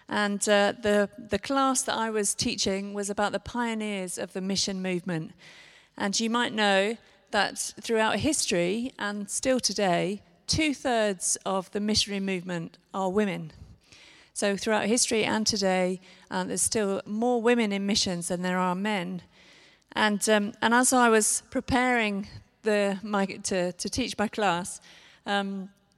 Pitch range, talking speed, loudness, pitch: 195-225 Hz, 150 wpm, -26 LUFS, 205 Hz